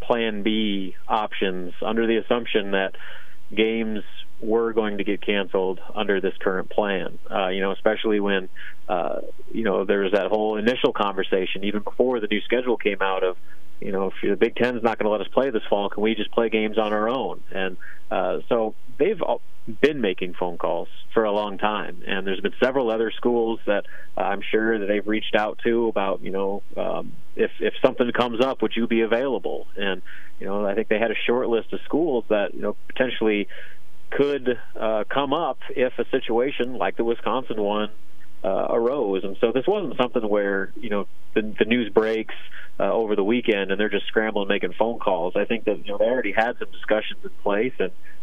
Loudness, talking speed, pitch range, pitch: -24 LUFS, 205 wpm, 100-115 Hz, 110 Hz